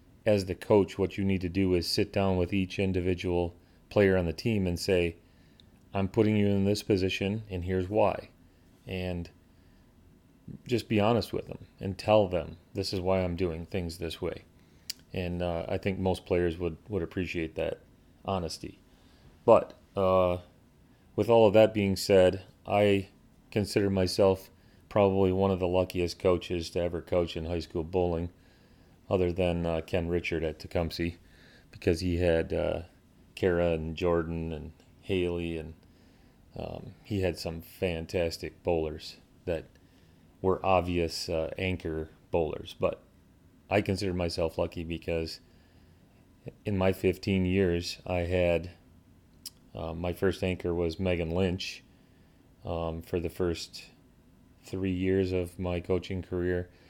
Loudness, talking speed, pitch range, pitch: -30 LUFS, 145 wpm, 85-95 Hz, 90 Hz